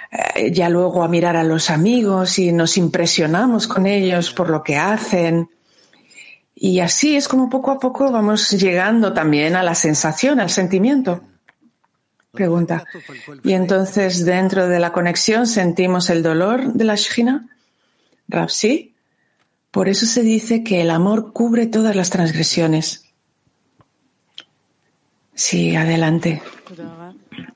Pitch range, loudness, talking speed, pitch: 170-220 Hz, -16 LUFS, 130 wpm, 185 Hz